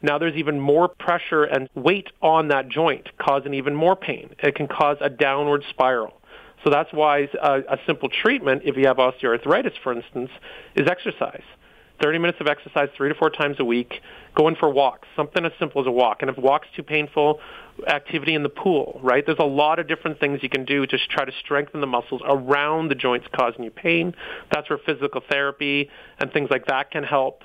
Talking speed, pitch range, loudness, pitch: 210 wpm, 135-155 Hz, -22 LUFS, 145 Hz